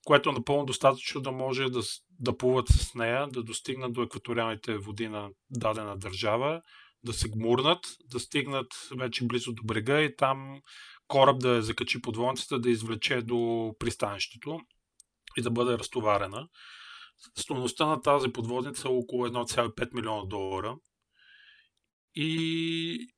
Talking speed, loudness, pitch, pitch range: 135 wpm, -30 LUFS, 125 Hz, 115-135 Hz